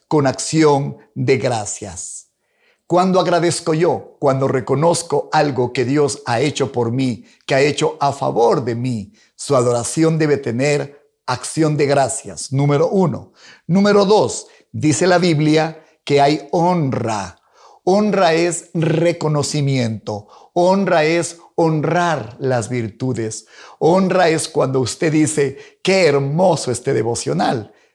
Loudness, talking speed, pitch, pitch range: -17 LUFS, 120 wpm, 145 Hz, 130-165 Hz